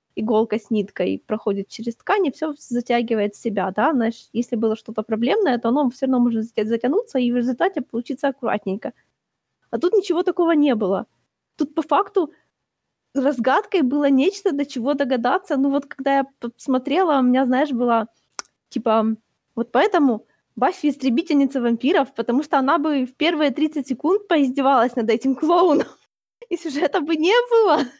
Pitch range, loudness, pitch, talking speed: 235-310 Hz, -21 LUFS, 270 Hz, 160 wpm